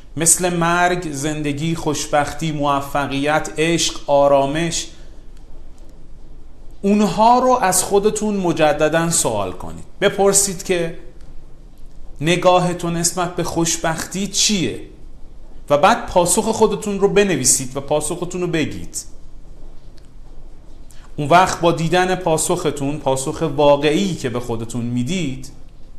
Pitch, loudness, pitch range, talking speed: 165 Hz, -17 LUFS, 145-180 Hz, 95 wpm